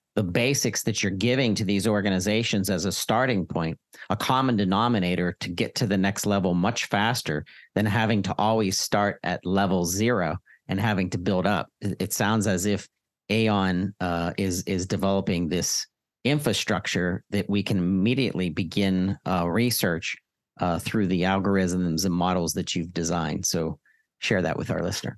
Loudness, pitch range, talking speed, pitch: -25 LUFS, 90-105 Hz, 165 wpm, 95 Hz